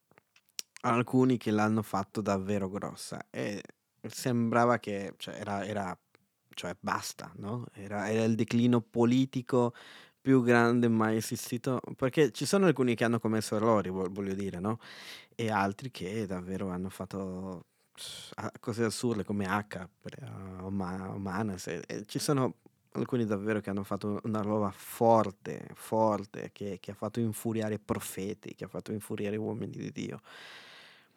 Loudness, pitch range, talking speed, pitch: -32 LUFS, 100-120 Hz, 135 wpm, 110 Hz